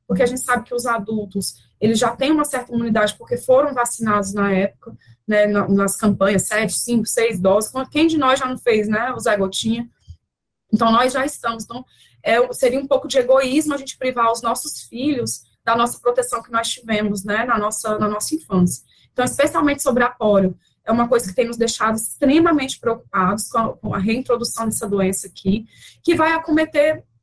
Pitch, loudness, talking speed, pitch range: 230 Hz, -18 LUFS, 195 wpm, 210-260 Hz